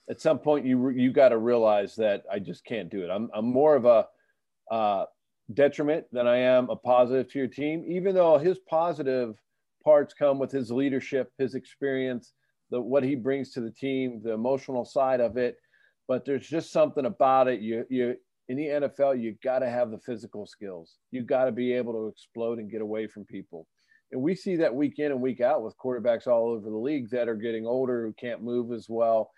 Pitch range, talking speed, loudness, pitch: 120-140 Hz, 215 wpm, -27 LUFS, 130 Hz